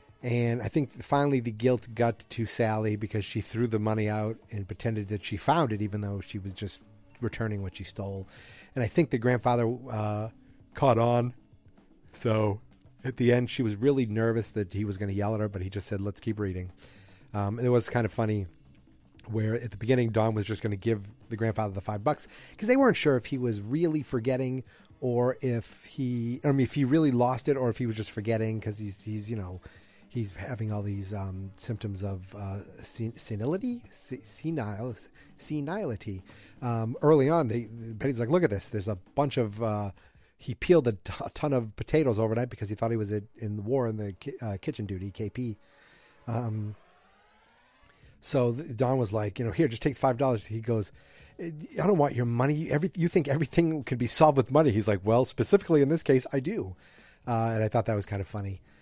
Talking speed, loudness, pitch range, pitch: 215 wpm, -29 LUFS, 105-130 Hz, 115 Hz